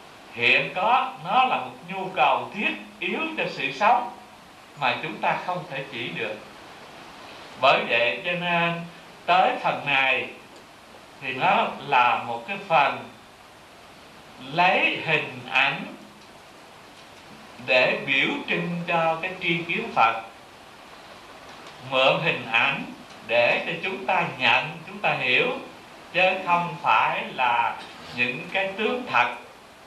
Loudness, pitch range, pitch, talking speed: -23 LUFS, 135-190 Hz, 175 Hz, 125 wpm